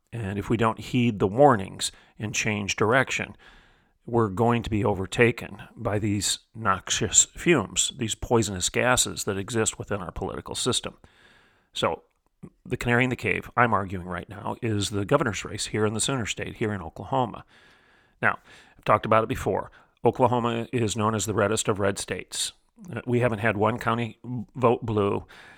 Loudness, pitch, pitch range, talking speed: -25 LUFS, 110 Hz, 100-120 Hz, 170 wpm